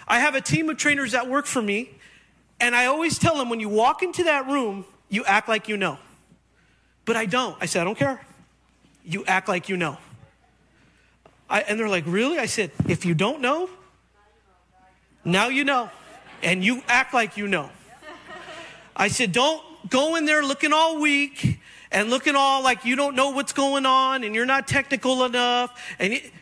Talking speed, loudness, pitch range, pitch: 195 wpm, -22 LUFS, 200-280 Hz, 245 Hz